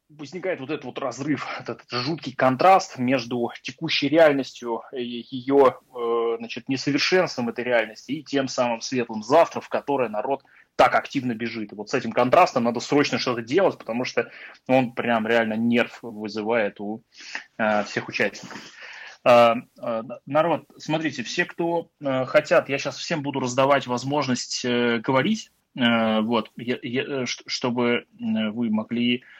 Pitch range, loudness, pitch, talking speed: 115-145 Hz, -23 LUFS, 125 Hz, 130 wpm